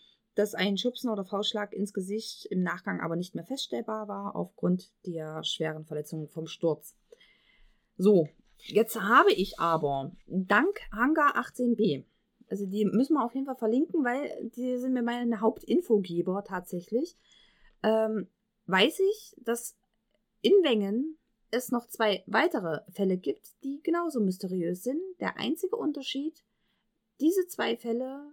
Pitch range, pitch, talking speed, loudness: 190-260 Hz, 220 Hz, 140 wpm, -29 LUFS